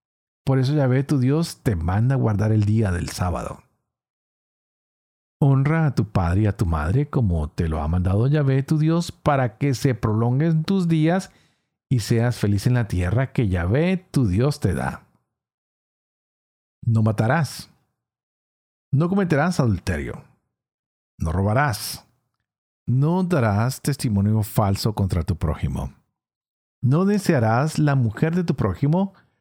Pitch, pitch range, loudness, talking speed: 120 Hz, 100-145 Hz, -22 LUFS, 140 wpm